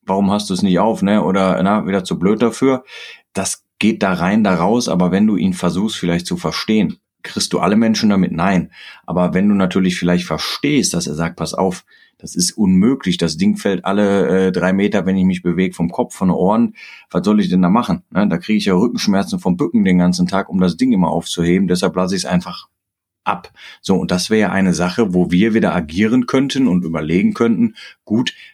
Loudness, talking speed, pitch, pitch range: -16 LUFS, 225 wpm, 95 Hz, 90-110 Hz